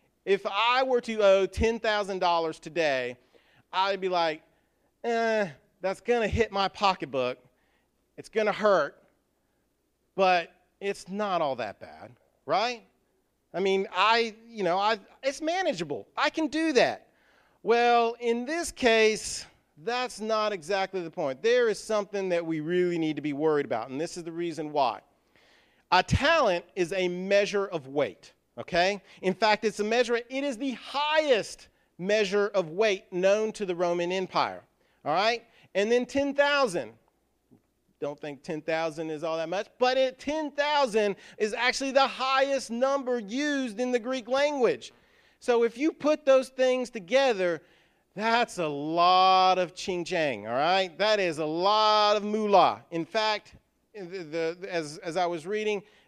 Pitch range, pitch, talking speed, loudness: 180-245 Hz, 205 Hz, 155 wpm, -27 LUFS